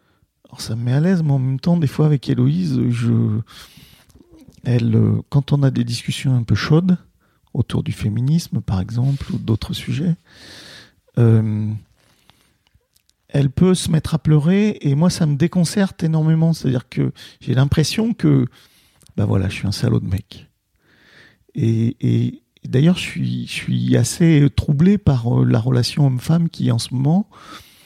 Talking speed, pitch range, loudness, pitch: 160 wpm, 115-160 Hz, -18 LUFS, 135 Hz